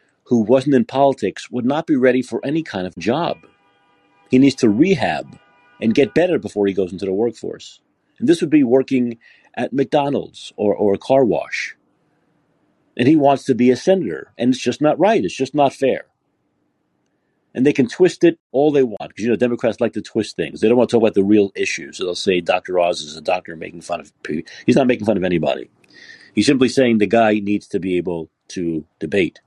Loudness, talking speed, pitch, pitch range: -18 LUFS, 220 wpm, 120 Hz, 100-135 Hz